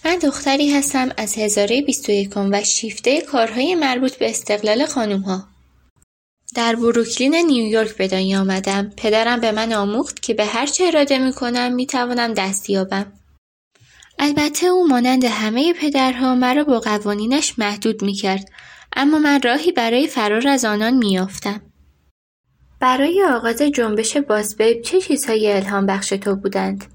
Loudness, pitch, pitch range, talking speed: -18 LUFS, 230 Hz, 205-270 Hz, 145 wpm